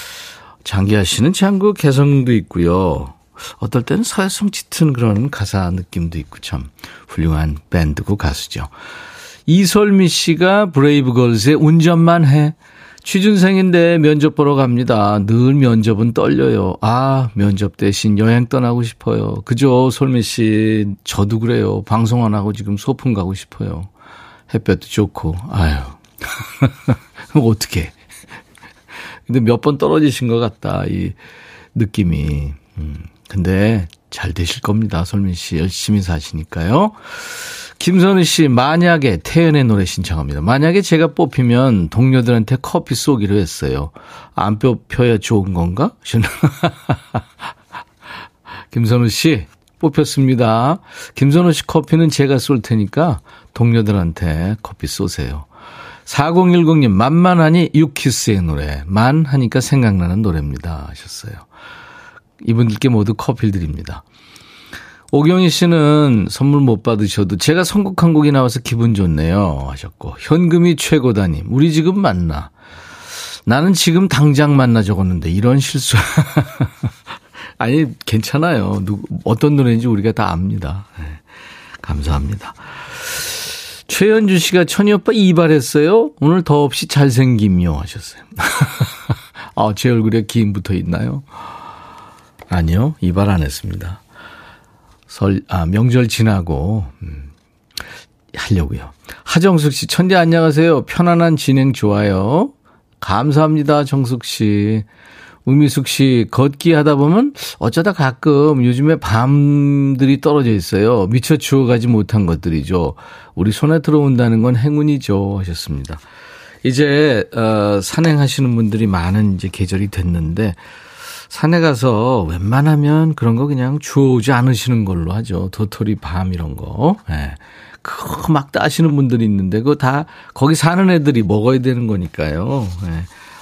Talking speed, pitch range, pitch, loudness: 270 characters per minute, 100-150 Hz, 120 Hz, -14 LUFS